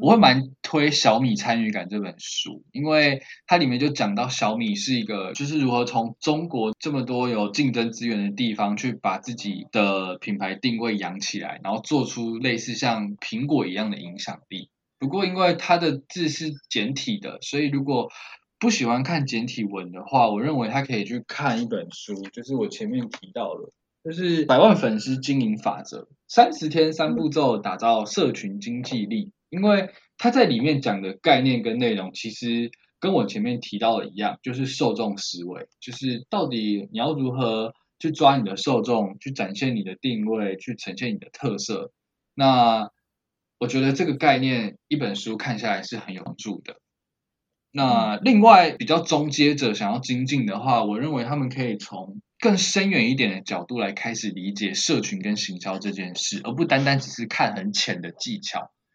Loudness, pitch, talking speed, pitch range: -23 LUFS, 130 Hz, 275 characters per minute, 115-170 Hz